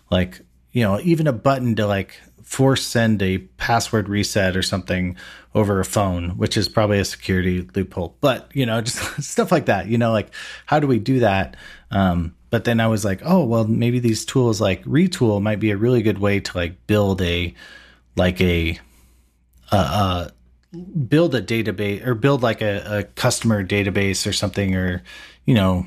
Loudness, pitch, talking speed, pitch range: -20 LUFS, 105 Hz, 190 wpm, 95-115 Hz